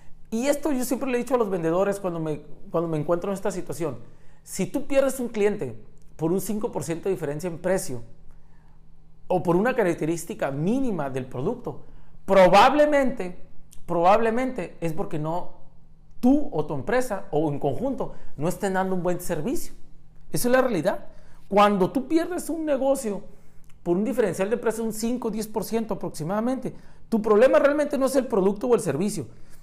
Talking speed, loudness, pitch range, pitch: 170 wpm, -24 LUFS, 165-245 Hz, 195 Hz